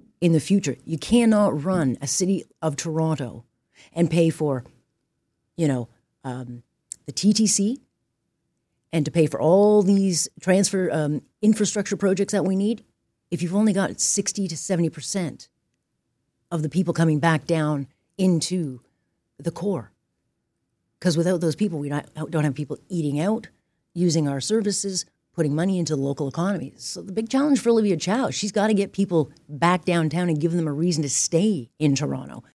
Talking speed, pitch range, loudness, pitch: 170 wpm, 150-195 Hz, -23 LUFS, 170 Hz